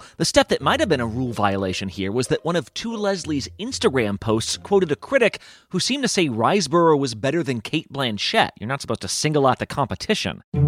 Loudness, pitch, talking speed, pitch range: -21 LUFS, 140 Hz, 220 wpm, 110-175 Hz